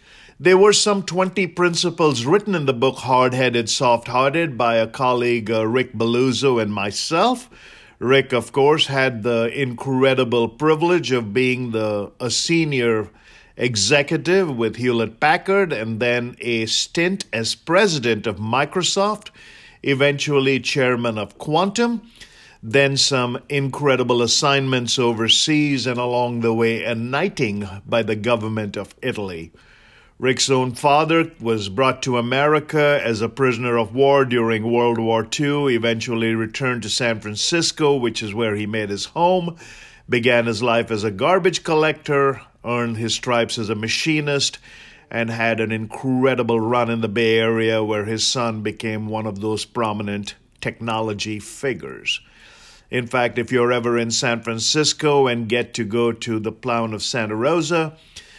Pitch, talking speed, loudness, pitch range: 120 Hz, 145 wpm, -19 LUFS, 115-140 Hz